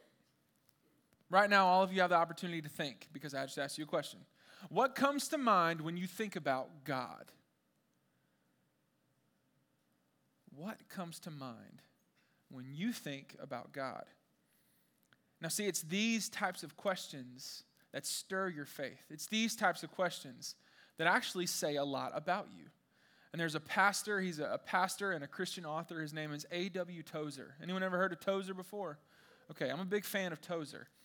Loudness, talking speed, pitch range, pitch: -37 LUFS, 170 wpm, 150-195 Hz, 175 Hz